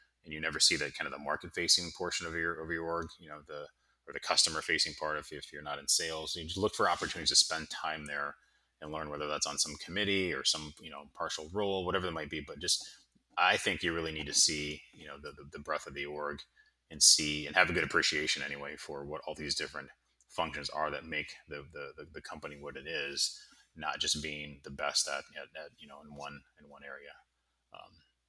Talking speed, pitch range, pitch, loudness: 240 wpm, 75-85 Hz, 75 Hz, -32 LUFS